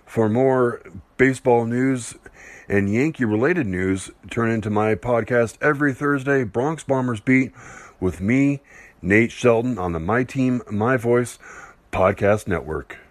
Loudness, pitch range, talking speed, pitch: -21 LUFS, 105-130 Hz, 135 wpm, 120 Hz